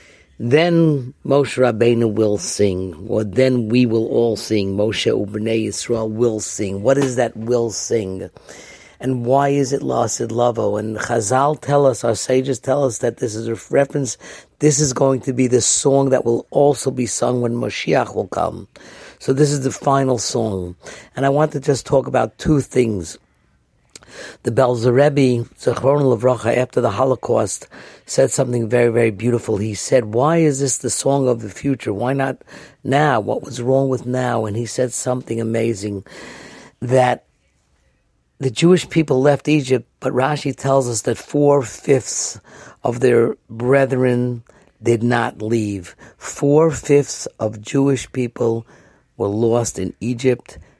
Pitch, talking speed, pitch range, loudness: 125 Hz, 160 wpm, 115-135 Hz, -18 LUFS